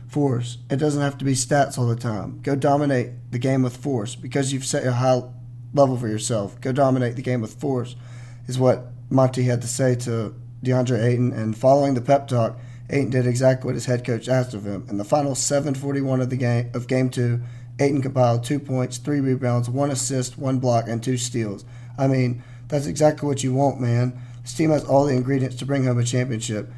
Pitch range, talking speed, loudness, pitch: 120-135 Hz, 215 wpm, -22 LUFS, 125 Hz